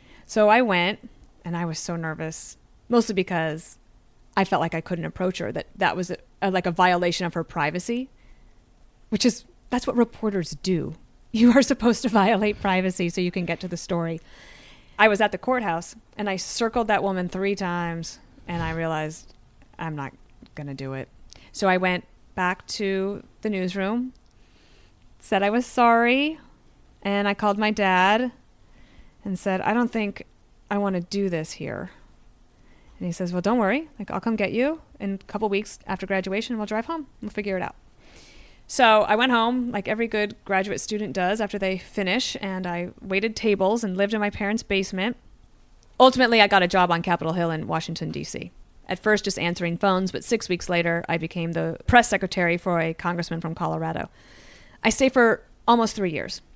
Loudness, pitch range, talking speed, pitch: -24 LUFS, 175-220 Hz, 190 wpm, 195 Hz